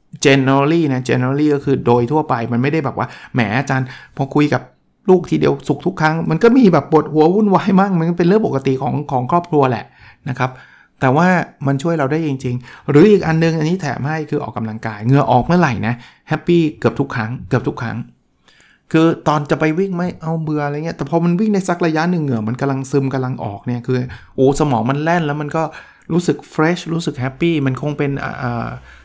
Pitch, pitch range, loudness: 145 Hz, 130-165 Hz, -16 LUFS